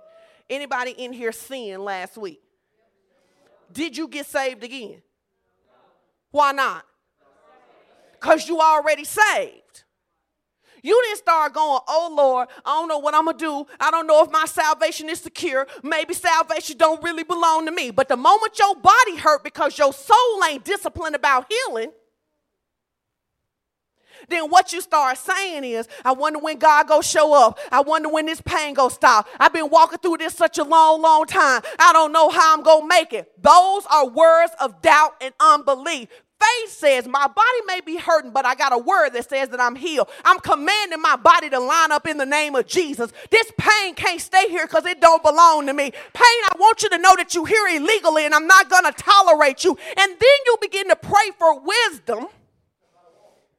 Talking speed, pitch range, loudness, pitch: 185 wpm, 290-360 Hz, -17 LUFS, 320 Hz